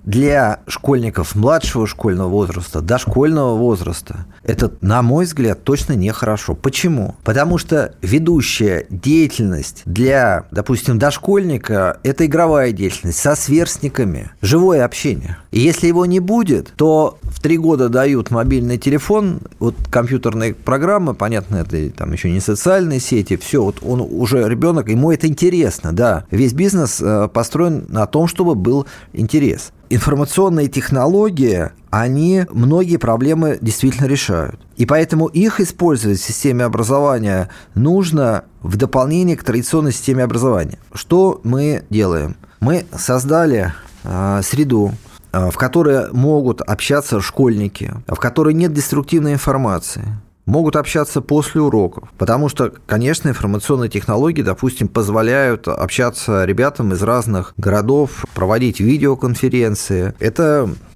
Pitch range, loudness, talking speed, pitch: 105-150 Hz, -16 LUFS, 125 wpm, 125 Hz